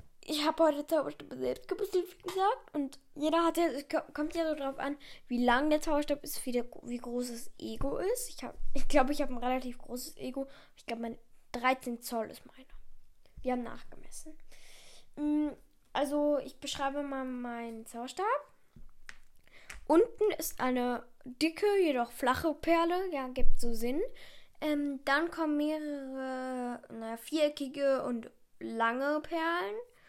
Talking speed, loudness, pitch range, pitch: 150 wpm, -33 LUFS, 250-320 Hz, 285 Hz